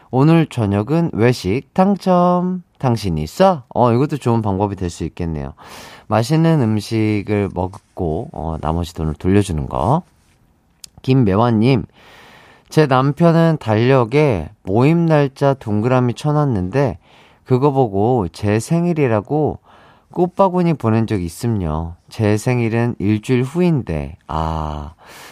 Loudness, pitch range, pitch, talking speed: -17 LUFS, 95-145 Hz, 115 Hz, 245 characters per minute